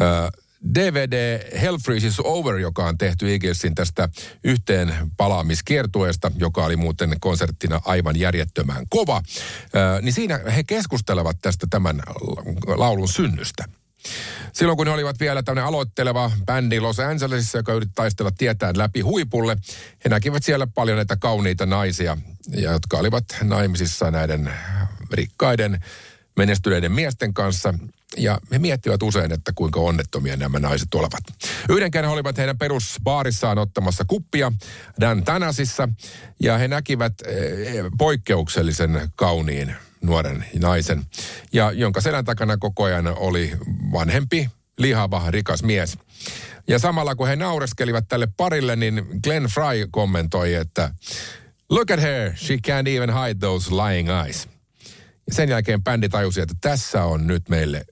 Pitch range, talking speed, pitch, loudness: 90-125 Hz, 135 wpm, 105 Hz, -21 LUFS